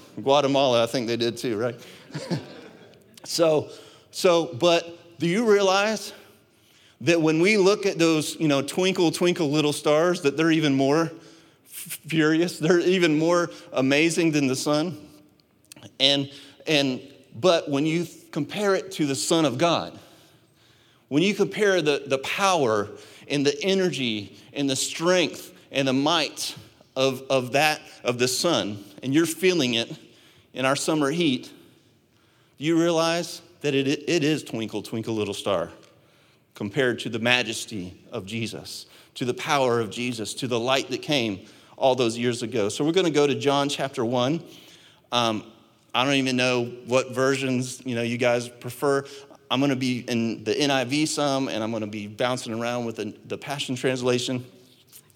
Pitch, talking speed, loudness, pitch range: 140 Hz, 160 wpm, -24 LUFS, 125-165 Hz